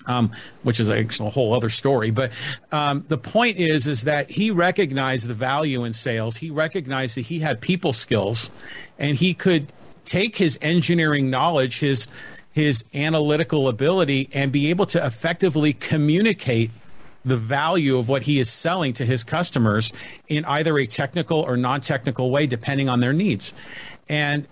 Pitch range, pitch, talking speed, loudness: 125-160 Hz, 140 Hz, 165 wpm, -21 LUFS